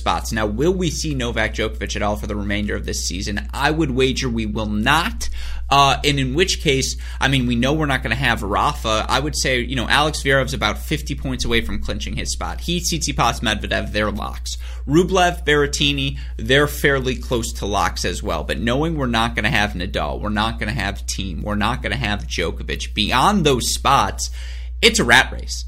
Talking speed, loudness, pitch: 215 wpm, -19 LUFS, 110 Hz